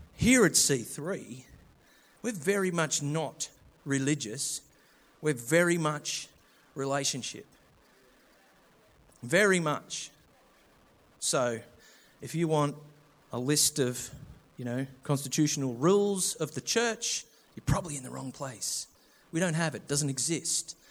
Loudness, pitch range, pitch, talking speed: -29 LUFS, 135-165 Hz, 145 Hz, 120 wpm